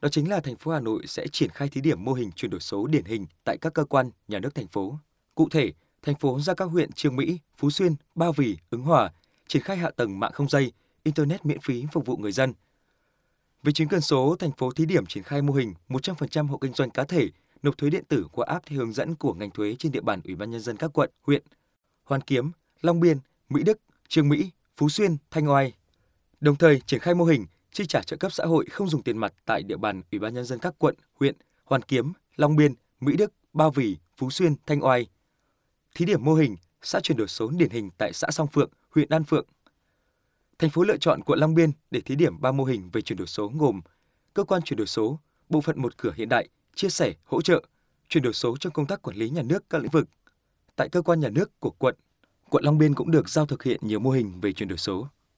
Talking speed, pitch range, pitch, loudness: 250 wpm, 130-160 Hz, 145 Hz, -25 LUFS